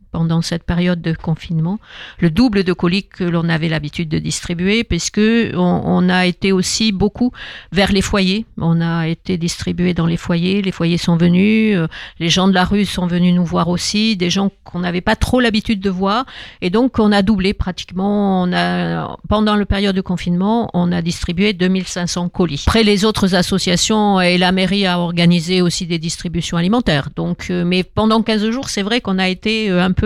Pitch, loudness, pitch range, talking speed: 185 Hz, -16 LUFS, 175-205 Hz, 195 wpm